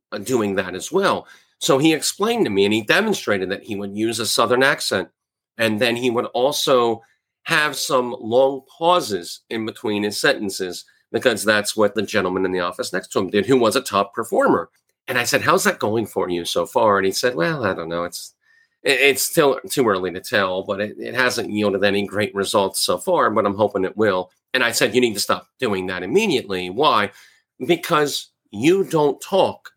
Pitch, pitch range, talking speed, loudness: 105 Hz, 95-130 Hz, 210 wpm, -20 LUFS